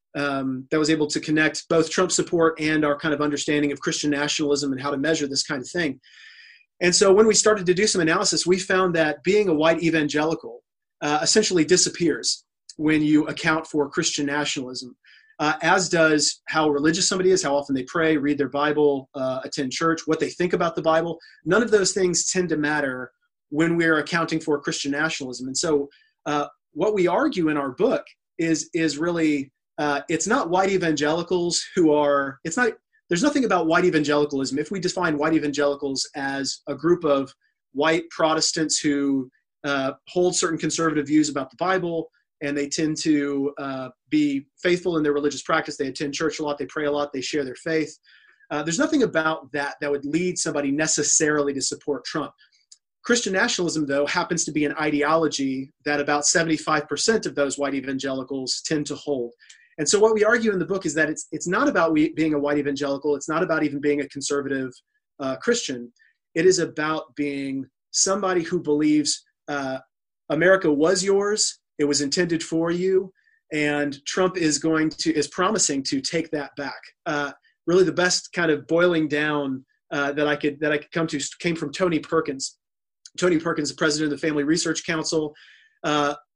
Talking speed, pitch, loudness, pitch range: 190 wpm, 155 Hz, -22 LUFS, 145-175 Hz